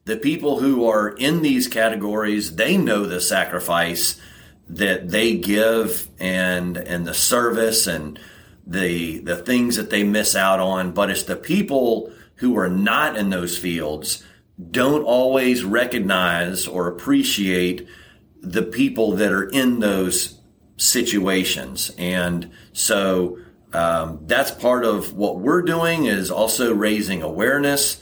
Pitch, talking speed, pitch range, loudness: 100 Hz, 135 wpm, 90-115 Hz, -20 LUFS